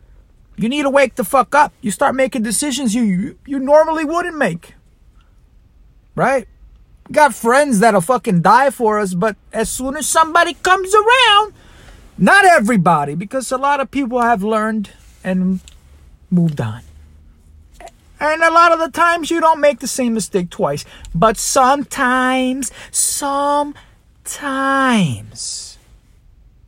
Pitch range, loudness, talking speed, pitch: 195-290 Hz, -15 LUFS, 135 wpm, 255 Hz